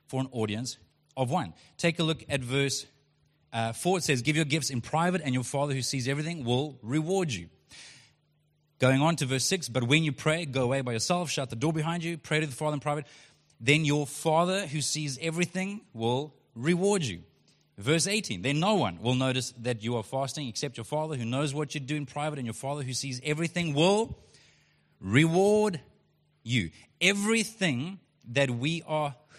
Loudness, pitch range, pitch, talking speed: -29 LUFS, 130-160 Hz, 145 Hz, 195 wpm